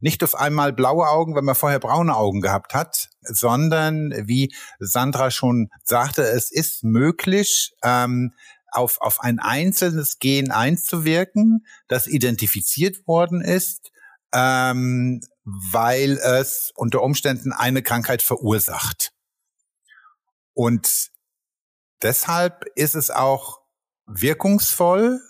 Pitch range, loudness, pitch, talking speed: 125-170 Hz, -20 LUFS, 135 Hz, 105 wpm